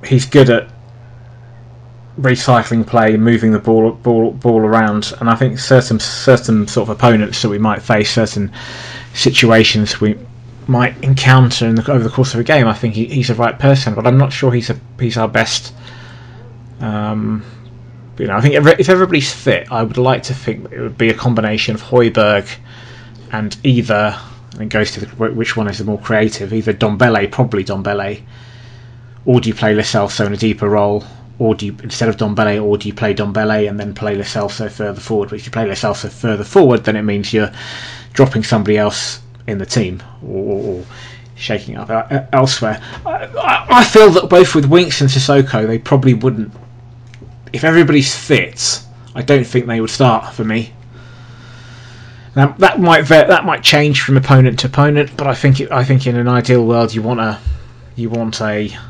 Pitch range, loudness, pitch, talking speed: 110-125 Hz, -13 LUFS, 120 Hz, 190 wpm